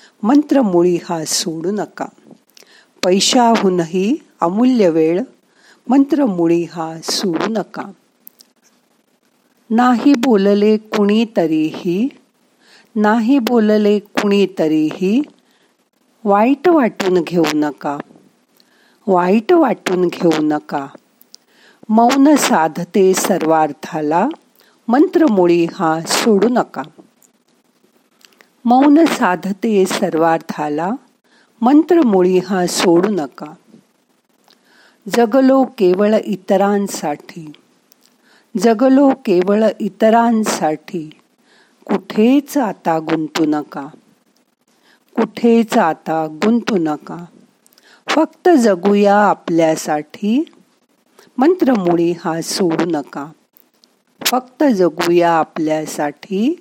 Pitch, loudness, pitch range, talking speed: 205 Hz, -15 LUFS, 170-250 Hz, 65 wpm